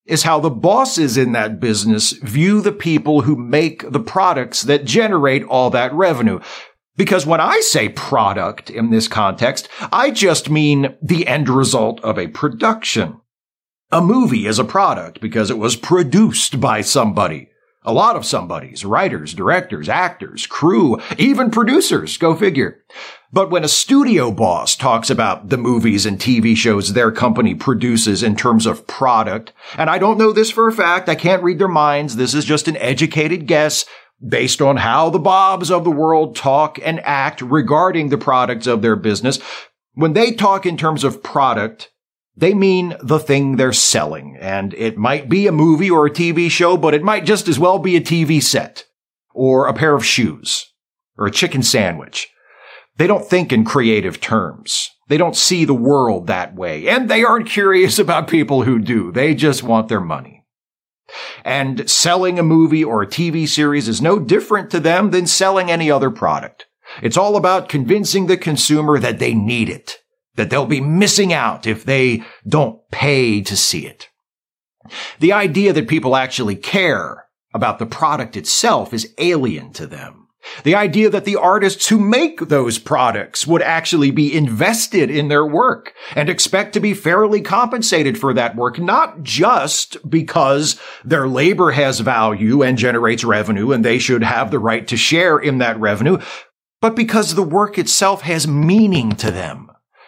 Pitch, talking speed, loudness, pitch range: 155 Hz, 175 wpm, -15 LUFS, 125-185 Hz